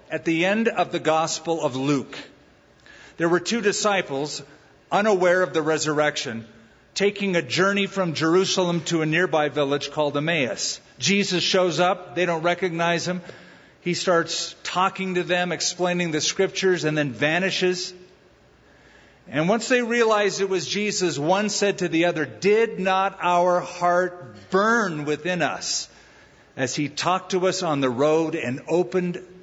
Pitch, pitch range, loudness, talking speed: 175 Hz, 155-185 Hz, -22 LUFS, 150 wpm